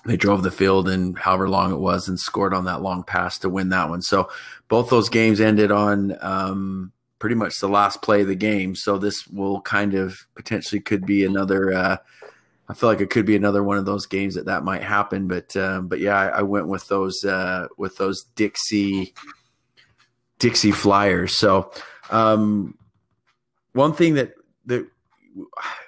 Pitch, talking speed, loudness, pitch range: 100 Hz, 185 wpm, -21 LUFS, 95-105 Hz